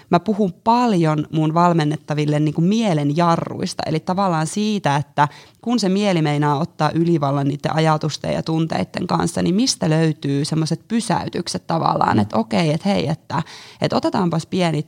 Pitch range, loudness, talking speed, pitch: 150-185 Hz, -19 LUFS, 150 wpm, 160 Hz